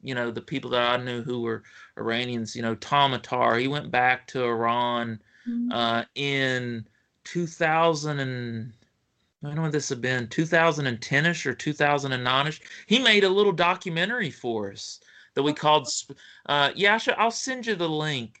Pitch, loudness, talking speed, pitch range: 135 Hz, -25 LUFS, 170 wpm, 120-160 Hz